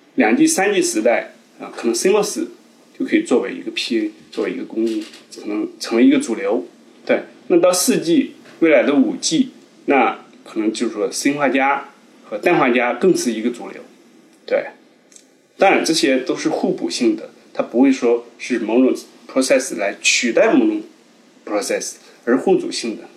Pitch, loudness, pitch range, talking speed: 320 Hz, -18 LUFS, 280-335 Hz, 275 characters per minute